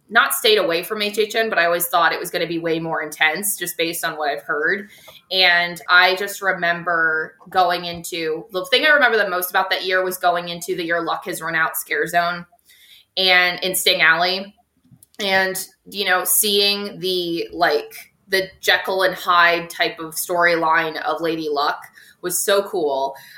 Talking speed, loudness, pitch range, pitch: 185 wpm, -18 LUFS, 170-190 Hz, 180 Hz